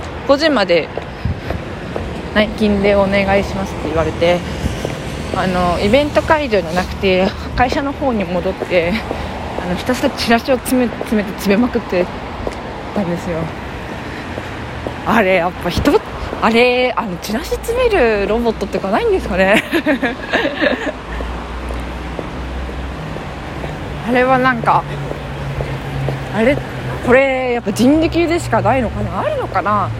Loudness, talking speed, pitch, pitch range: -17 LUFS, 250 characters per minute, 215 Hz, 180-260 Hz